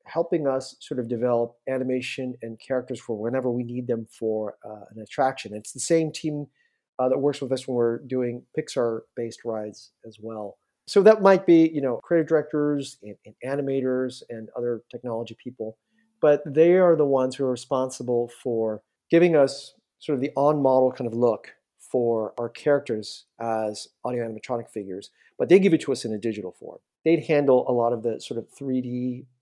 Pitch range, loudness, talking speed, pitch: 115-140 Hz, -24 LUFS, 190 wpm, 125 Hz